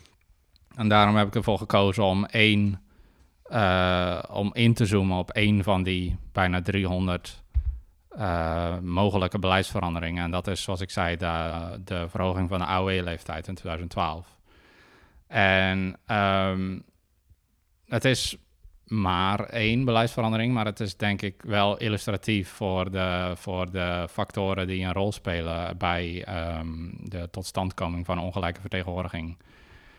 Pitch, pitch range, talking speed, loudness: 95 Hz, 85-100 Hz, 135 wpm, -26 LUFS